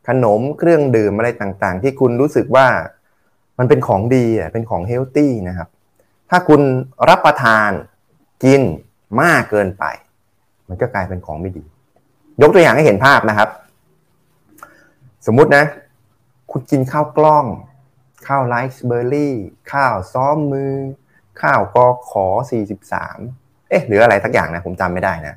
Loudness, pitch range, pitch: -14 LUFS, 100-135 Hz, 120 Hz